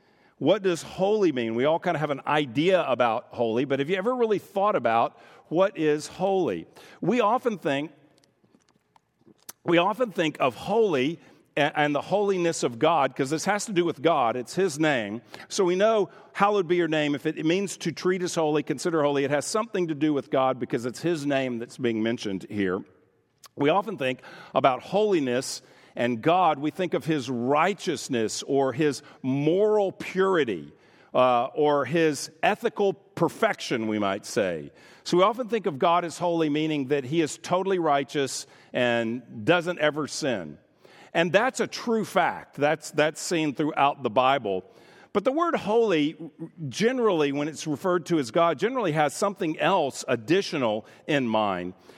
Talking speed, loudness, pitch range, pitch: 170 wpm, -25 LUFS, 140-185 Hz, 155 Hz